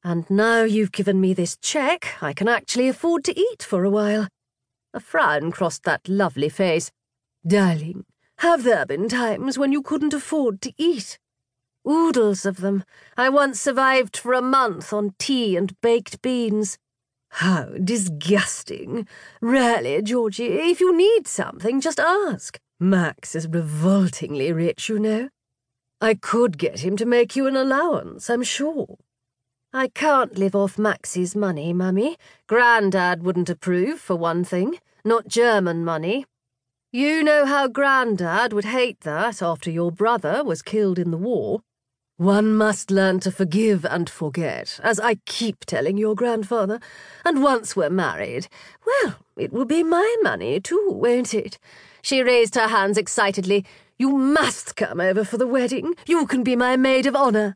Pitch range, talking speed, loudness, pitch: 180-260 Hz, 155 wpm, -21 LUFS, 215 Hz